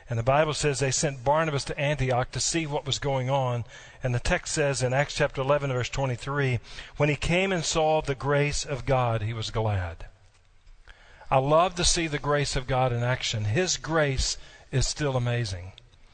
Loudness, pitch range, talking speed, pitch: -26 LUFS, 120-145 Hz, 195 wpm, 135 Hz